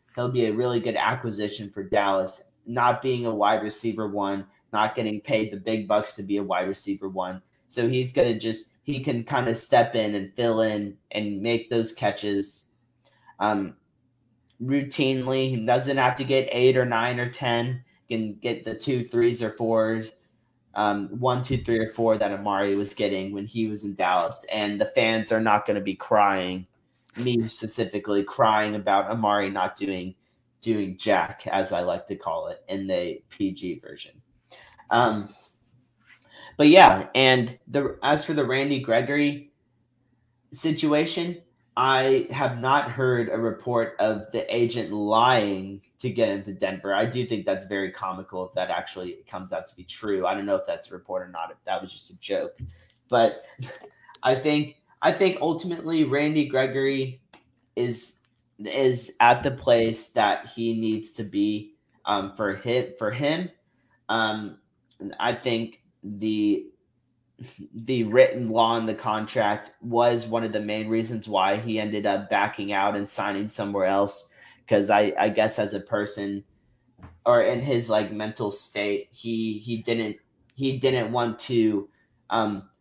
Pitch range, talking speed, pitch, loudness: 105-125 Hz, 165 wpm, 115 Hz, -25 LUFS